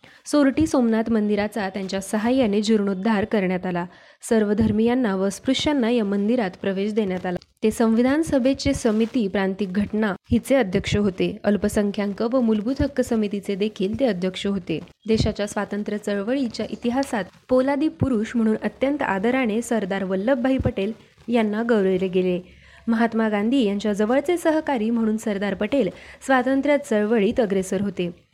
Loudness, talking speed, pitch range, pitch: -22 LUFS, 130 wpm, 200-245 Hz, 220 Hz